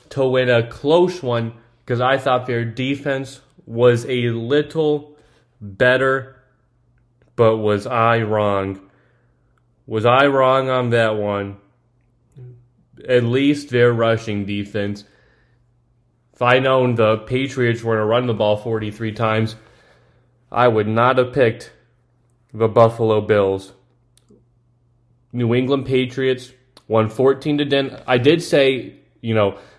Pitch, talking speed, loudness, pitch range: 120 Hz, 125 wpm, -18 LUFS, 115-130 Hz